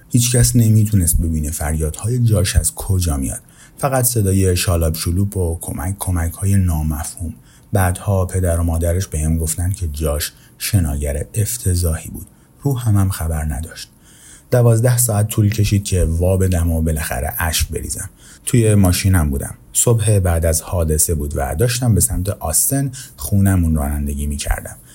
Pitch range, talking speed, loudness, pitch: 80-105 Hz, 150 wpm, -17 LUFS, 90 Hz